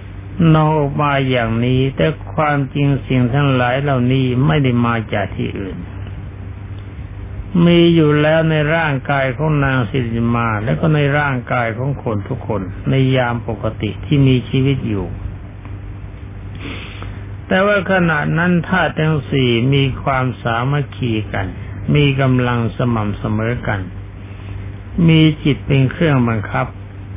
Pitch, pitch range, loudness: 125 Hz, 100-140 Hz, -16 LUFS